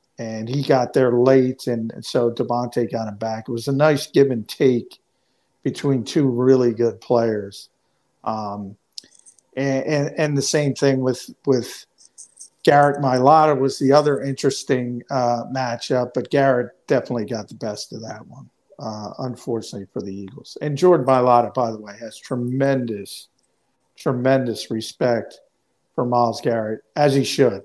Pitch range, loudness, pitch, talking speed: 115-135 Hz, -20 LUFS, 125 Hz, 155 wpm